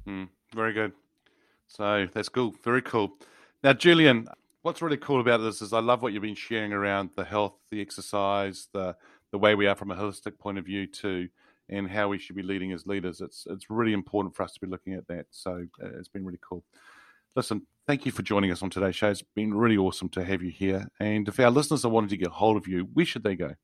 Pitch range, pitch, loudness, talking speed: 95-110 Hz, 100 Hz, -27 LUFS, 245 wpm